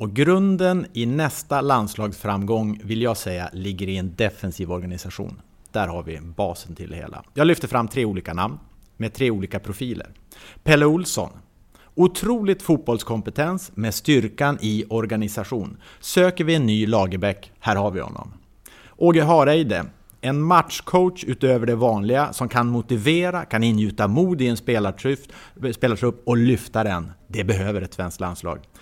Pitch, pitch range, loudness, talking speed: 110 Hz, 100-140 Hz, -22 LUFS, 150 wpm